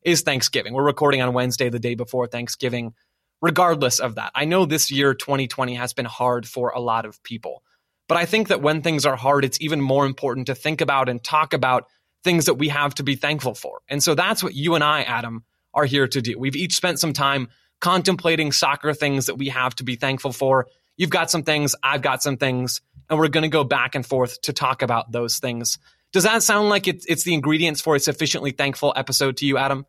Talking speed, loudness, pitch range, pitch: 230 wpm, -21 LUFS, 125-155 Hz, 140 Hz